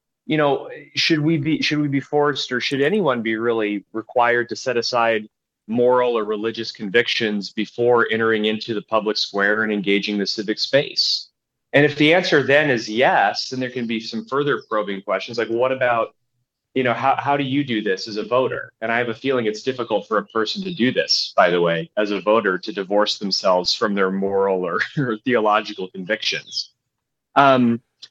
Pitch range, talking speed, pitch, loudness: 105-130 Hz, 195 wpm, 115 Hz, -20 LUFS